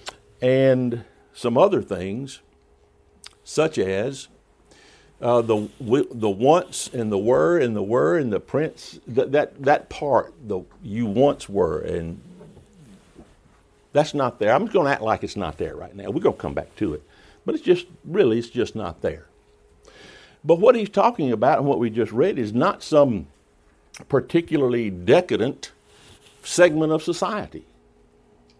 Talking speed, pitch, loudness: 155 wpm, 120 Hz, -22 LUFS